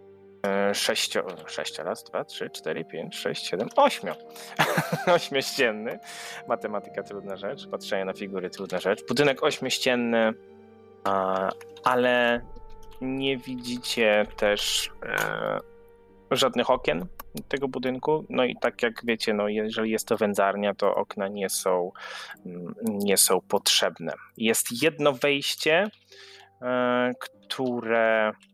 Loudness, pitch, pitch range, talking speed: -26 LUFS, 110 Hz, 100-130 Hz, 105 wpm